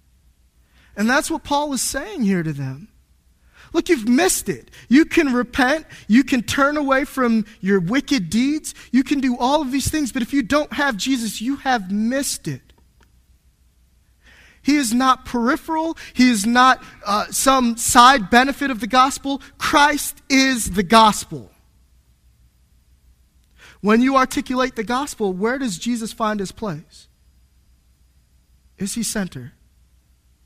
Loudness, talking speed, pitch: -18 LUFS, 145 wpm, 230 Hz